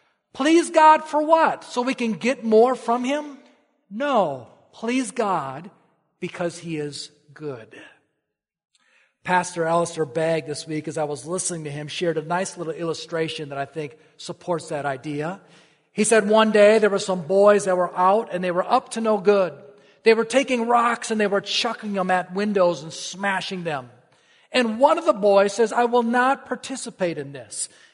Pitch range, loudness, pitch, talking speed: 160-235 Hz, -21 LUFS, 190 Hz, 180 wpm